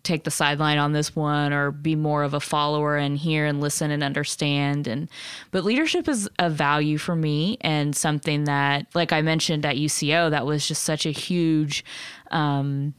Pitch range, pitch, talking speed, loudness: 145-160 Hz, 150 Hz, 190 wpm, -23 LUFS